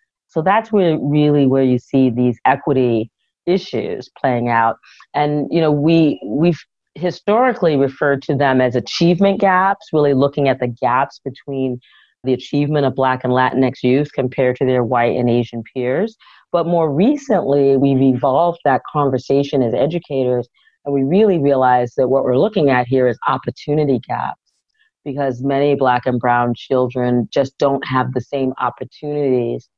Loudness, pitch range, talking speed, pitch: -17 LUFS, 125-150 Hz, 155 wpm, 135 Hz